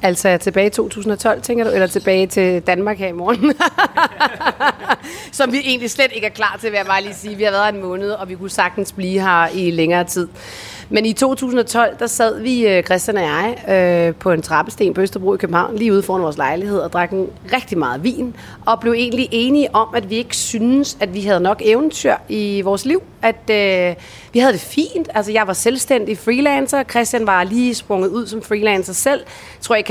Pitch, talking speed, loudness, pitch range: 210 Hz, 215 wpm, -17 LUFS, 190-235 Hz